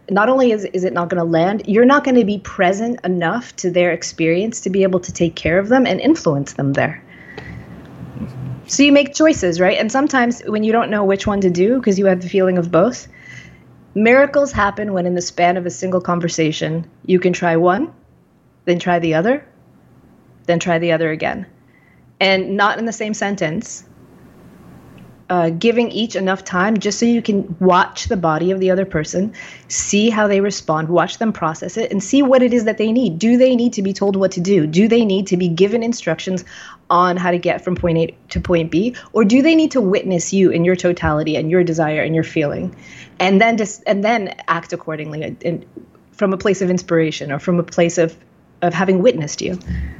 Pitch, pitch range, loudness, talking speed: 185 Hz, 170-215 Hz, -16 LUFS, 215 wpm